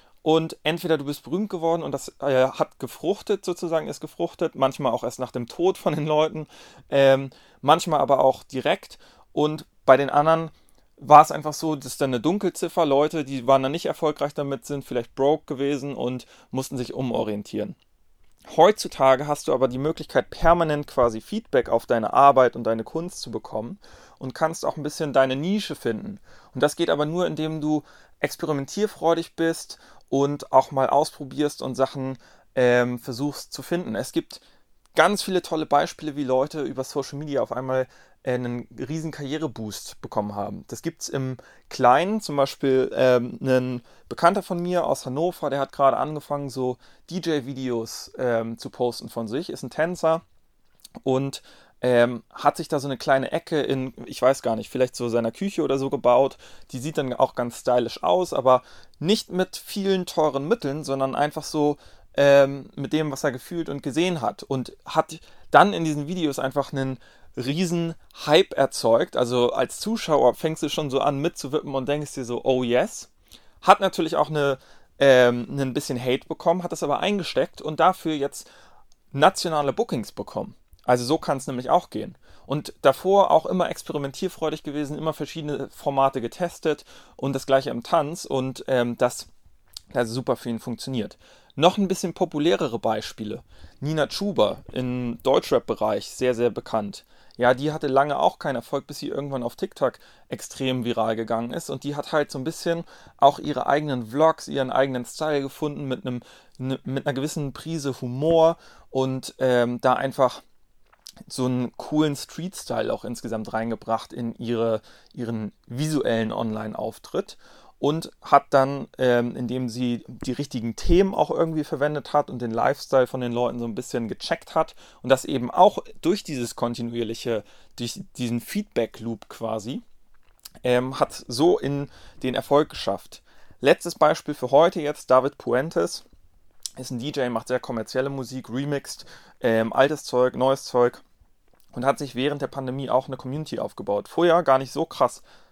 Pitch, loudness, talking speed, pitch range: 140 Hz, -24 LUFS, 165 wpm, 125-155 Hz